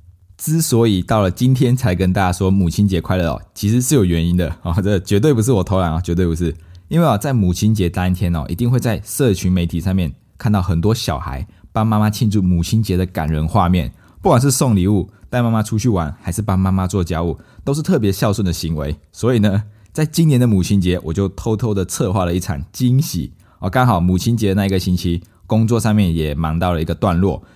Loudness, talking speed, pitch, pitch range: -17 LUFS, 335 characters per minute, 95 Hz, 90-110 Hz